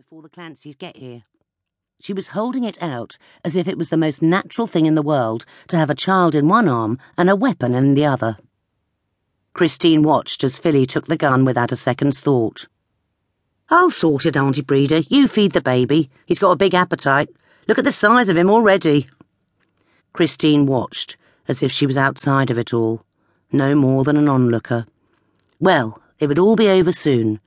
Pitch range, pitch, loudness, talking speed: 125-175 Hz, 145 Hz, -17 LUFS, 190 wpm